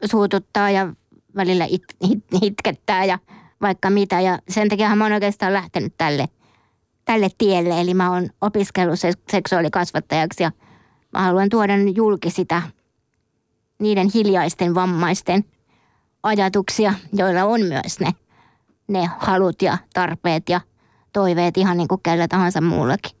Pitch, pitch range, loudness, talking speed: 185 Hz, 175-200 Hz, -19 LUFS, 130 wpm